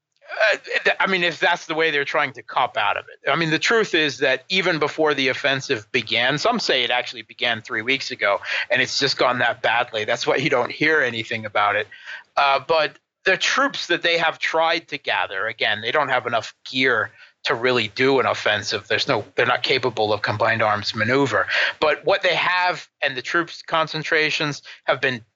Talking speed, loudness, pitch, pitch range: 210 wpm, -20 LUFS, 150 Hz, 125-170 Hz